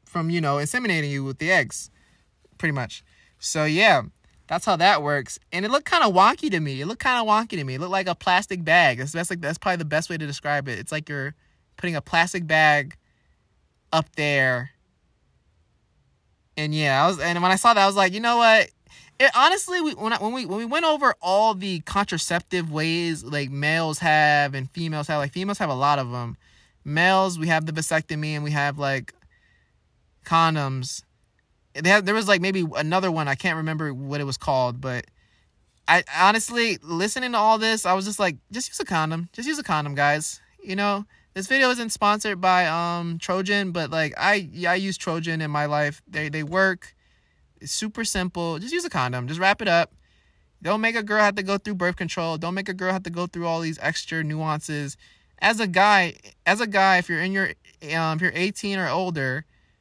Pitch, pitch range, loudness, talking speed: 170 Hz, 150-195 Hz, -22 LUFS, 215 wpm